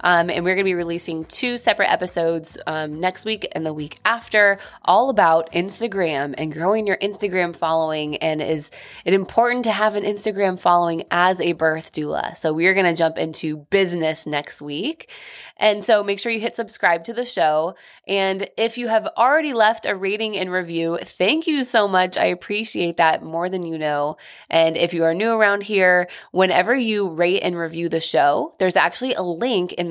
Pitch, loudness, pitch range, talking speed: 185 Hz, -20 LUFS, 165-215 Hz, 195 wpm